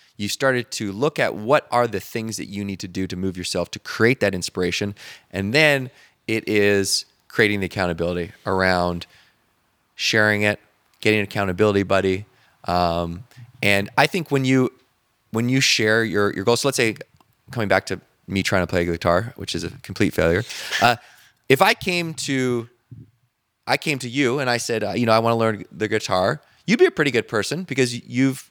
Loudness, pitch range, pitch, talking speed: -21 LUFS, 95-125 Hz, 110 Hz, 195 wpm